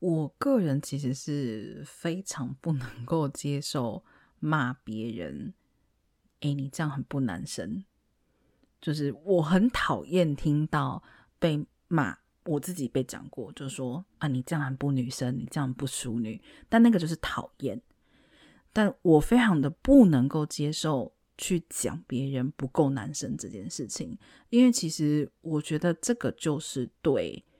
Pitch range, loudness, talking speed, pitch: 135-170 Hz, -28 LUFS, 215 characters per minute, 150 Hz